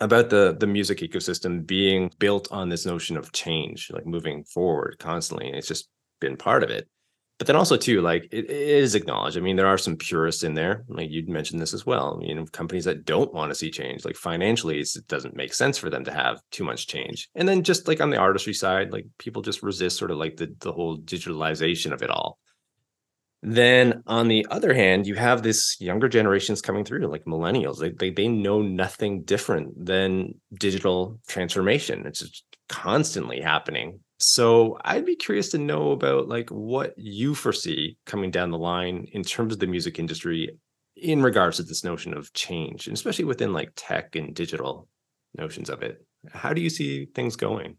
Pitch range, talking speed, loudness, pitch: 90-120 Hz, 205 wpm, -24 LUFS, 100 Hz